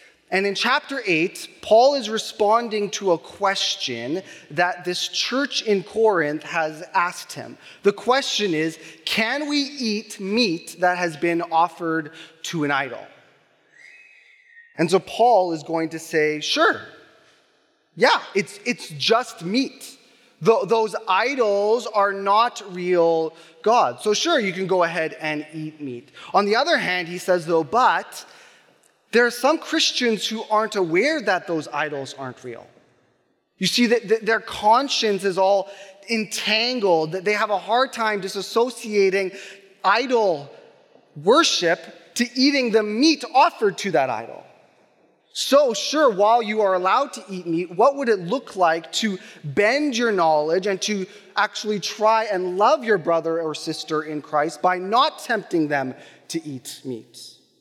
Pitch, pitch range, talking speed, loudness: 200 Hz, 165-230 Hz, 150 wpm, -21 LUFS